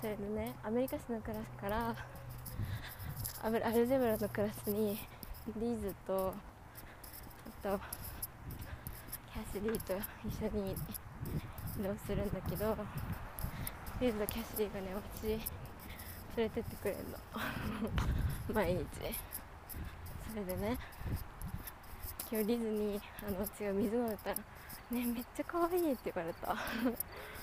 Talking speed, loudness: 230 characters per minute, -40 LUFS